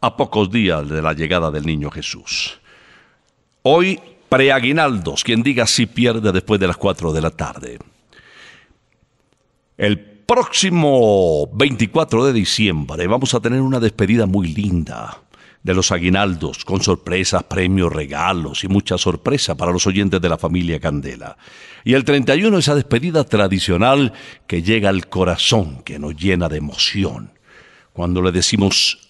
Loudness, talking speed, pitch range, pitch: -17 LUFS, 140 wpm, 85-120 Hz, 95 Hz